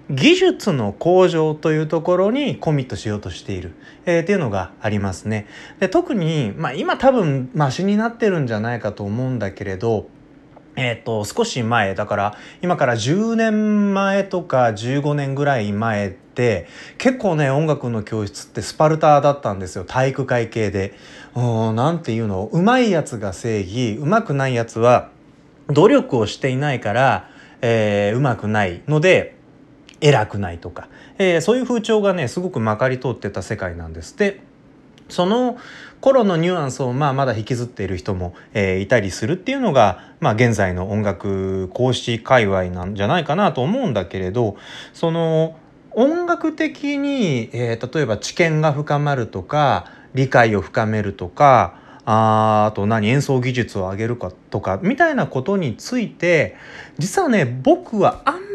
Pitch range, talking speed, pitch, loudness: 105-175 Hz, 320 characters per minute, 135 Hz, -19 LUFS